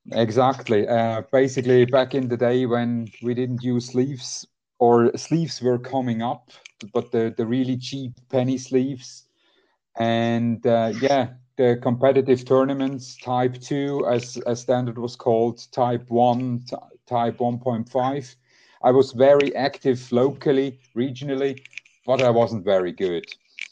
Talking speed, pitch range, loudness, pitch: 135 wpm, 120-130 Hz, -22 LUFS, 125 Hz